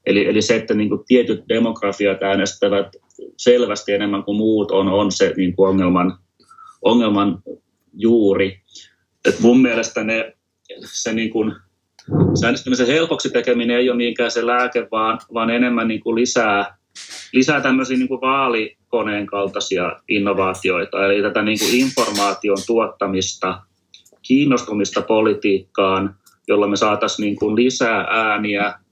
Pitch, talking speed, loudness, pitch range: 105 Hz, 135 wpm, -18 LUFS, 100-120 Hz